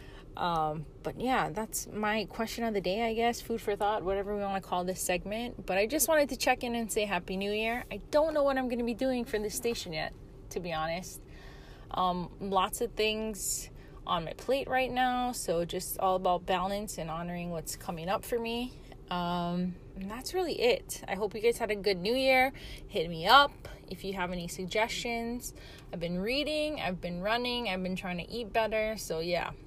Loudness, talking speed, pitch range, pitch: -31 LUFS, 215 wpm, 180-240 Hz, 215 Hz